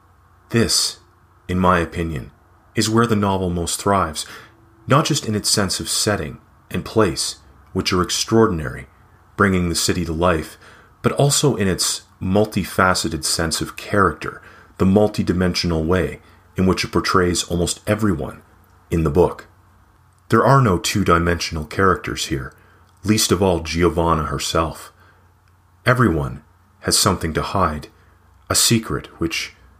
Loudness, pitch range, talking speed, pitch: -19 LUFS, 85-105 Hz, 135 wpm, 90 Hz